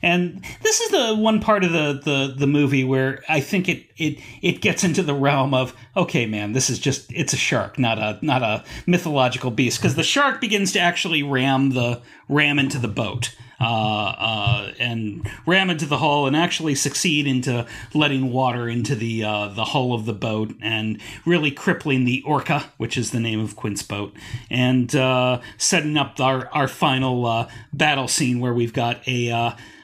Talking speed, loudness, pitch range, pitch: 195 wpm, -21 LUFS, 120-150 Hz, 130 Hz